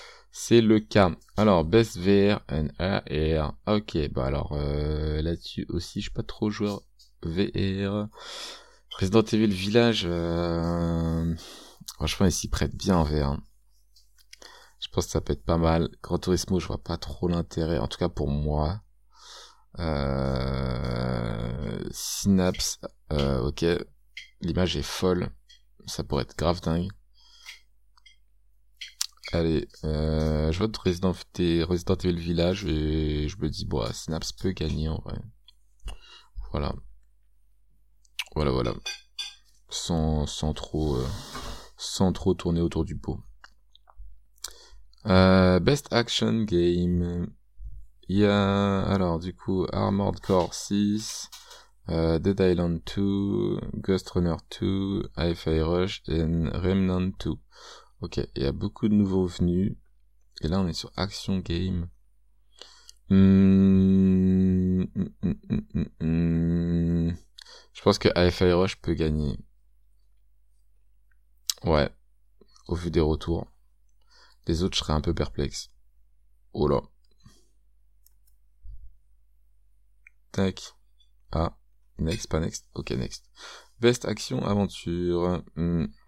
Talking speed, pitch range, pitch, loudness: 120 wpm, 70-95 Hz, 85 Hz, -26 LUFS